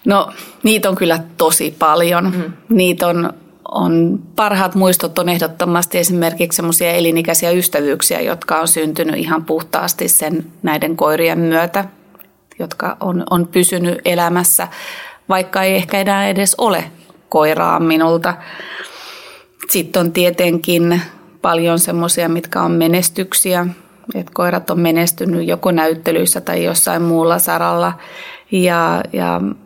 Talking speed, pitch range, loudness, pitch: 120 wpm, 165-180 Hz, -14 LUFS, 175 Hz